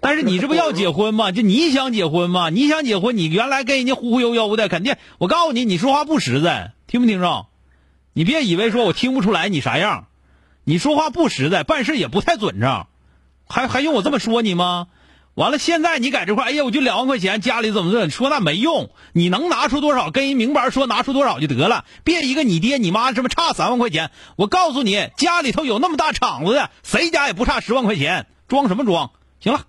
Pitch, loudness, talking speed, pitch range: 255 Hz, -18 LUFS, 340 characters per minute, 215-295 Hz